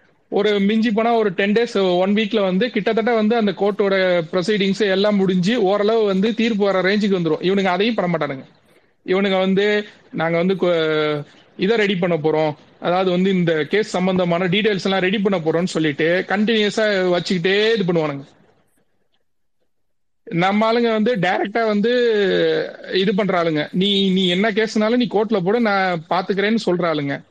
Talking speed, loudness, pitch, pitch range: 145 wpm, -18 LUFS, 195 Hz, 180-215 Hz